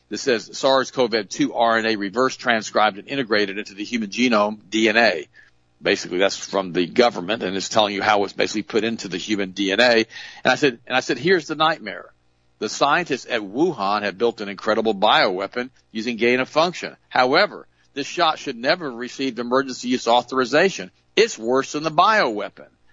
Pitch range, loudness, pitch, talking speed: 100-130 Hz, -20 LUFS, 115 Hz, 175 wpm